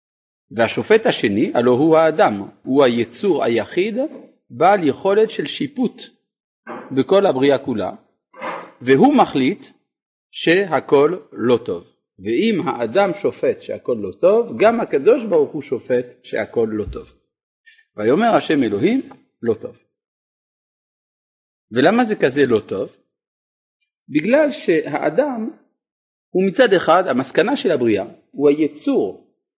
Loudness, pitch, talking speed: -18 LUFS, 245 Hz, 110 wpm